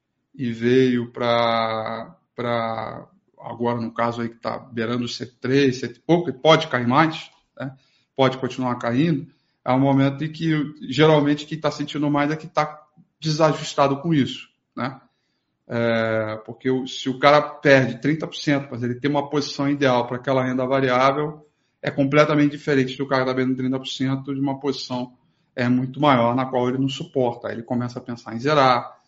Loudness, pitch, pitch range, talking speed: -21 LUFS, 130 Hz, 120-145 Hz, 170 wpm